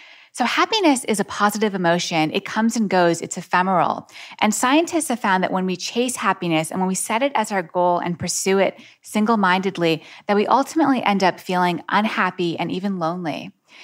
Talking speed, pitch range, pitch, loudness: 185 wpm, 180-220 Hz, 190 Hz, -20 LUFS